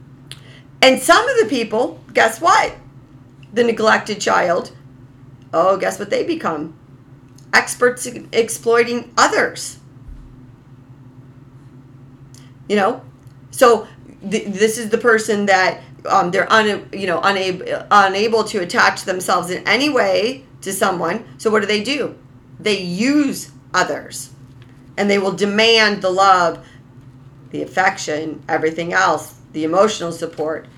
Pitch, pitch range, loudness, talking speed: 165 Hz, 130-215 Hz, -16 LUFS, 125 wpm